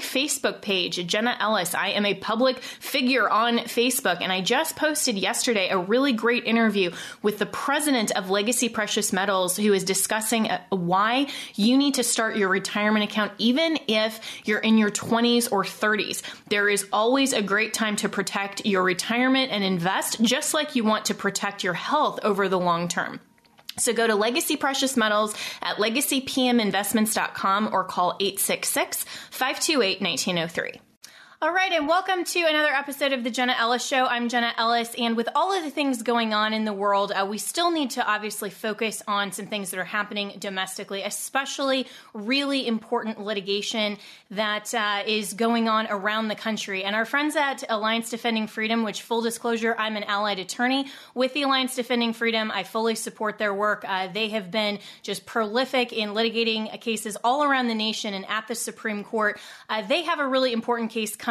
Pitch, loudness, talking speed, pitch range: 220 Hz, -24 LUFS, 180 wpm, 205-250 Hz